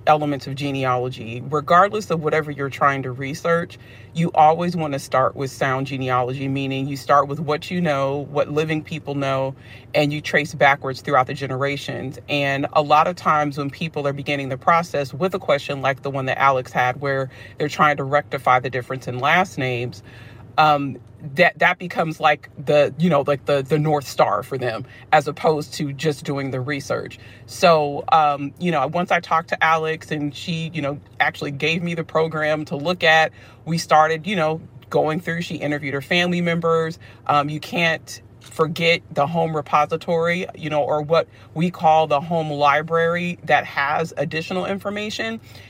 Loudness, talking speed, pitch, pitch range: -20 LUFS, 185 wpm, 145 Hz, 135-160 Hz